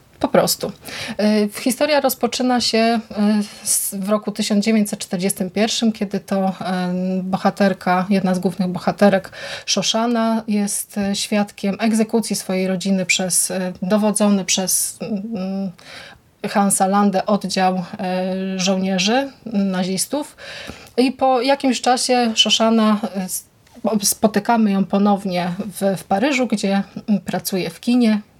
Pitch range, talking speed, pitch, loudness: 190-225 Hz, 95 wpm, 205 Hz, -19 LUFS